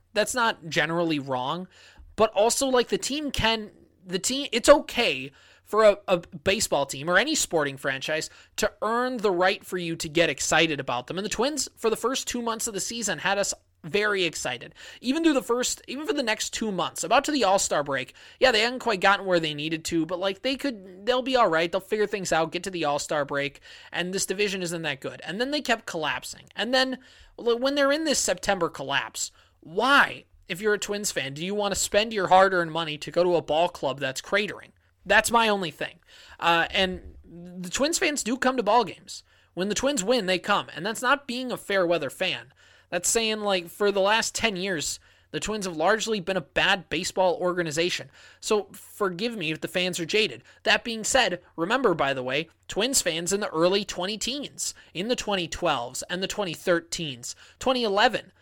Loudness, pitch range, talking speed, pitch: -25 LUFS, 165-225 Hz, 210 wpm, 190 Hz